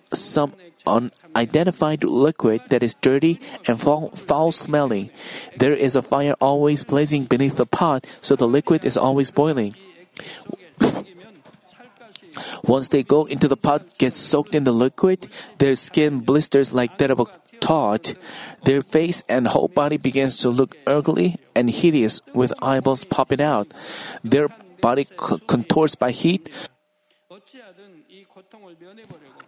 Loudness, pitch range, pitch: -19 LUFS, 130-165 Hz, 145 Hz